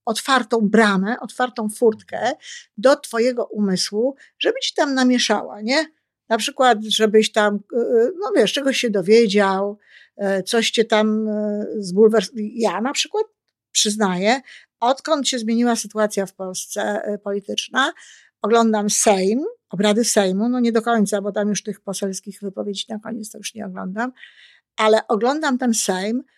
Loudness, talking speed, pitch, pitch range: -19 LUFS, 135 wpm, 220 Hz, 210-250 Hz